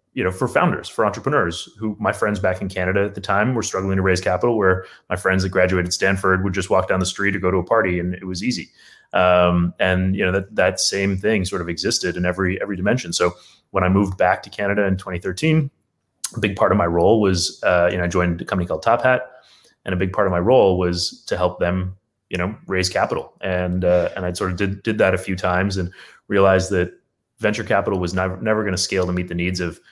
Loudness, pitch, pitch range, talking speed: -20 LUFS, 95 Hz, 90-100 Hz, 250 wpm